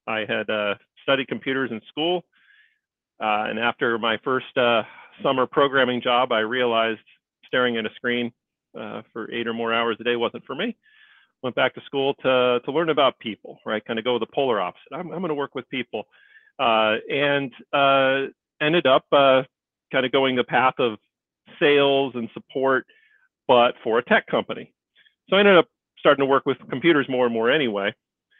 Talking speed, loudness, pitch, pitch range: 190 wpm, -22 LUFS, 130 Hz, 115-140 Hz